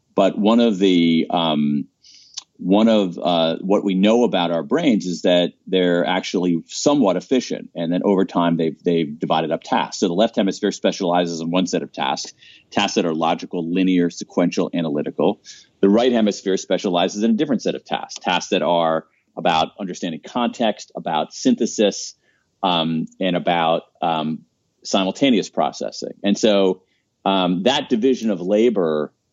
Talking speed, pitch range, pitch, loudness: 160 wpm, 85-100 Hz, 90 Hz, -20 LUFS